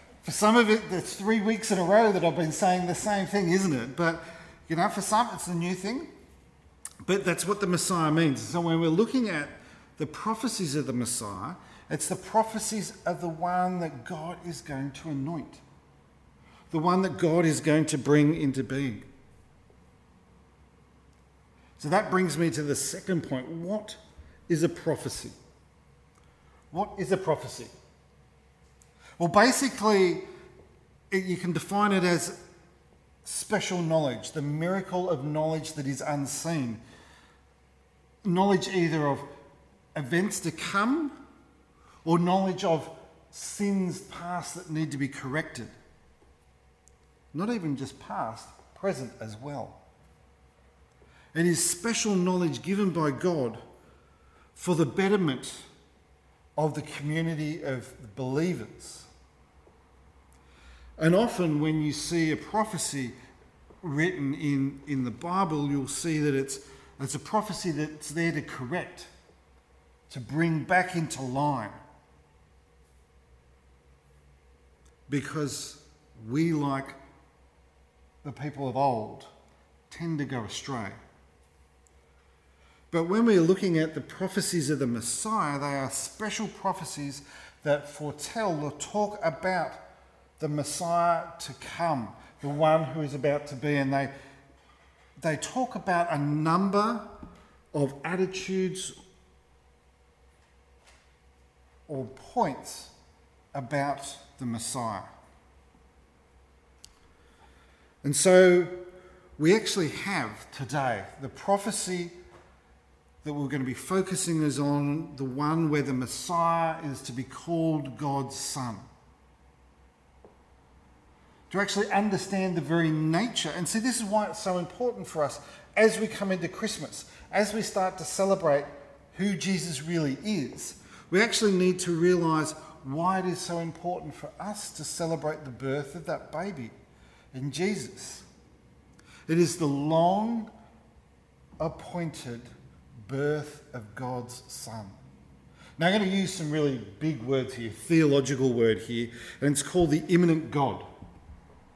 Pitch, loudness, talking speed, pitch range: 150 Hz, -28 LUFS, 130 wpm, 110-175 Hz